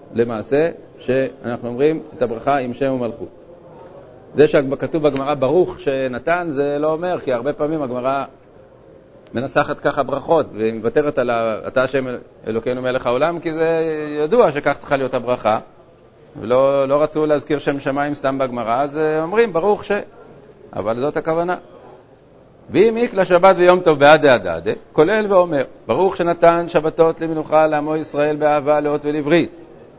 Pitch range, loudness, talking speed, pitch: 130-160 Hz, -18 LUFS, 140 wpm, 150 Hz